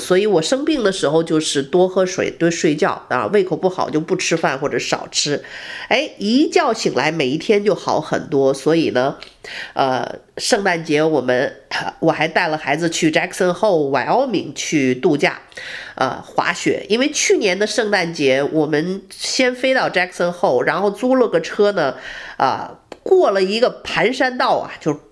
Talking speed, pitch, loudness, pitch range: 295 characters per minute, 185 Hz, -18 LUFS, 155-225 Hz